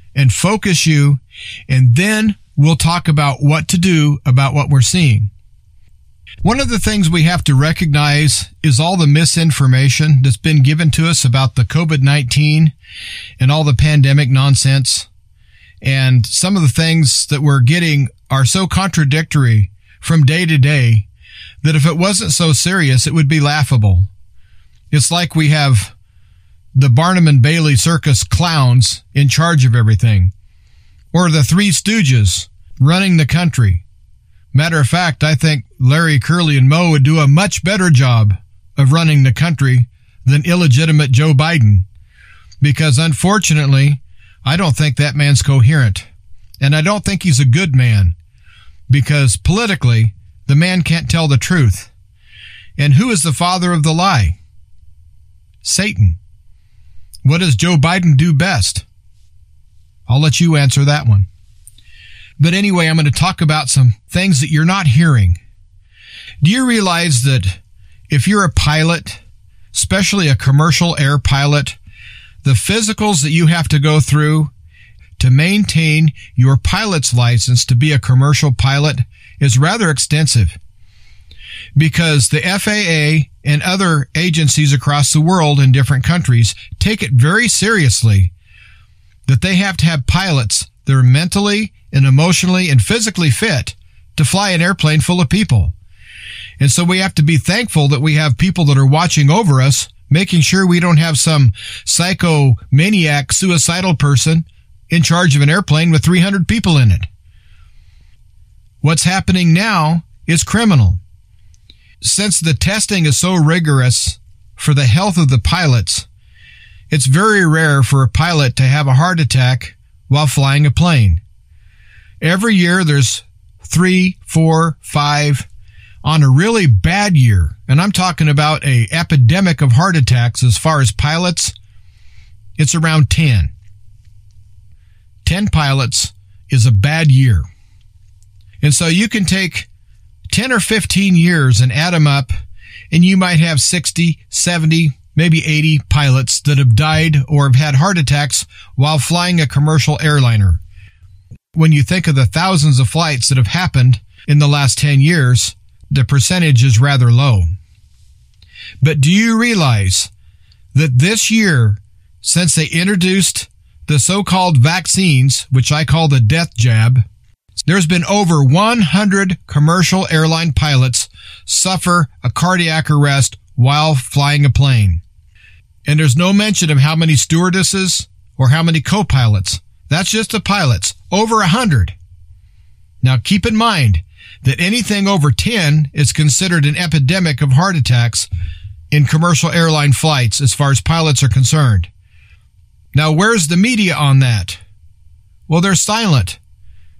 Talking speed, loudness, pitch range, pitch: 145 wpm, -12 LUFS, 105-160 Hz, 140 Hz